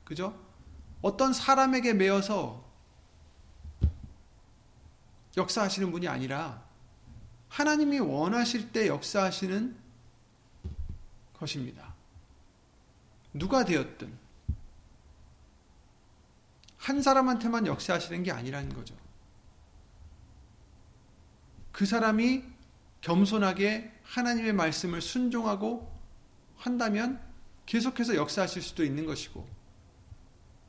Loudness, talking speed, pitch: -30 LUFS, 190 characters per minute, 170 Hz